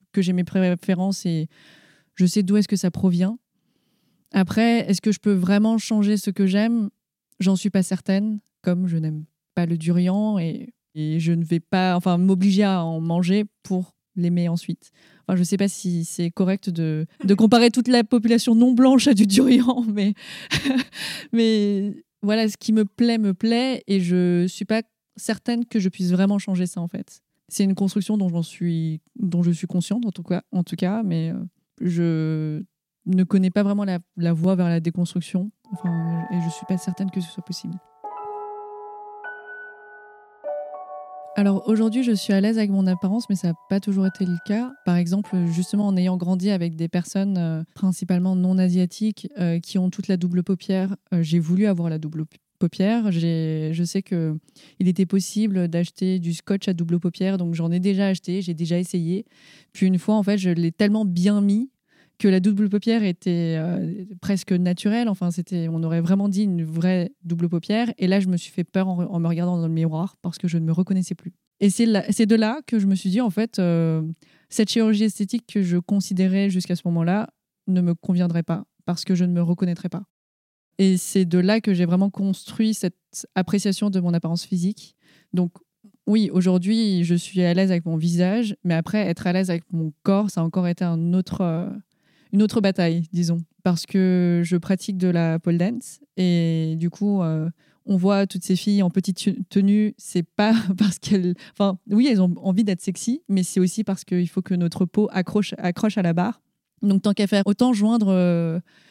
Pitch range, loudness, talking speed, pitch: 175-205 Hz, -22 LUFS, 200 wpm, 190 Hz